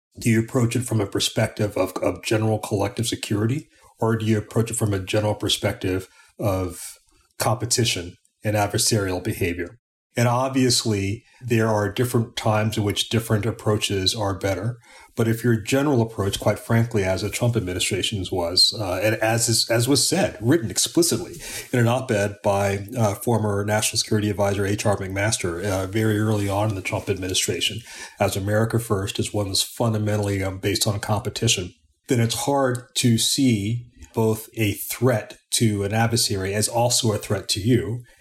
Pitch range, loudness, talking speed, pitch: 100-115 Hz, -22 LUFS, 170 wpm, 110 Hz